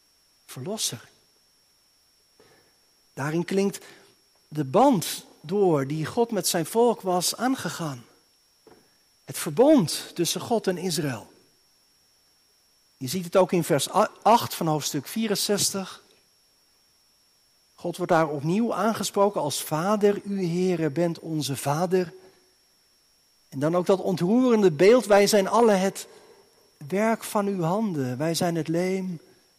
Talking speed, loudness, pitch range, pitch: 120 wpm, -24 LUFS, 160-205 Hz, 185 Hz